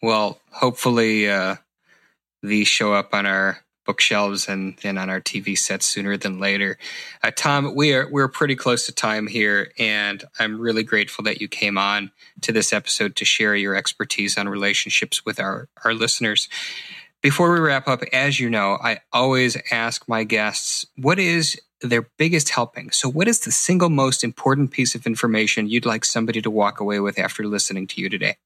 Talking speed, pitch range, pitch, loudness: 185 wpm, 100-130 Hz, 115 Hz, -20 LUFS